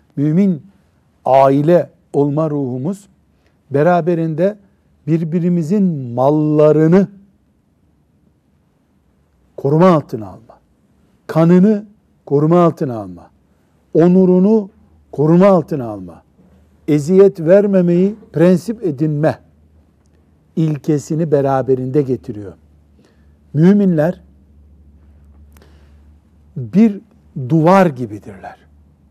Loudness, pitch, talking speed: -14 LUFS, 145 Hz, 60 wpm